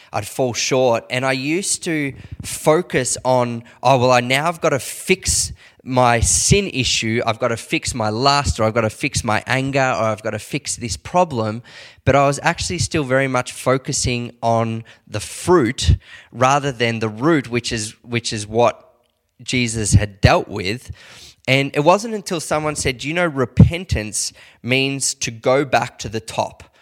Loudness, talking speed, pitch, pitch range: -18 LUFS, 180 wpm, 125 Hz, 110-140 Hz